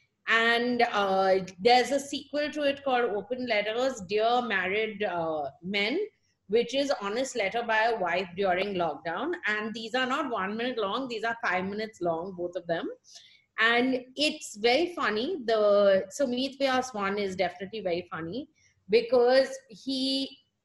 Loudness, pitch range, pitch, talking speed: -28 LUFS, 190-260 Hz, 225 Hz, 155 wpm